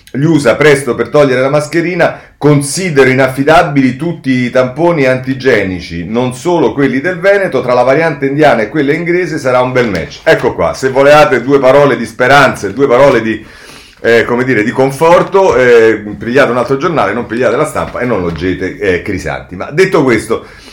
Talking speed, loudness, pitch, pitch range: 180 wpm, -10 LUFS, 135 Hz, 120-155 Hz